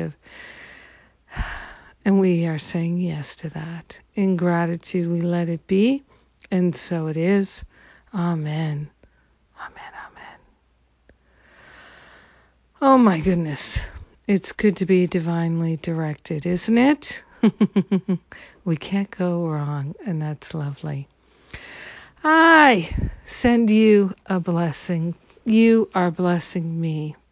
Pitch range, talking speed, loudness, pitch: 155-195 Hz, 105 wpm, -21 LUFS, 175 Hz